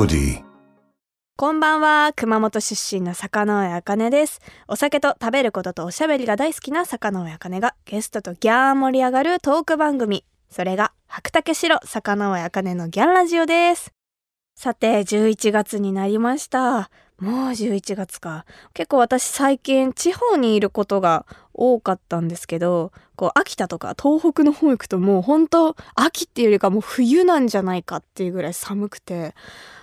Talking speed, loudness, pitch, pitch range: 305 characters per minute, -20 LUFS, 220 Hz, 190-285 Hz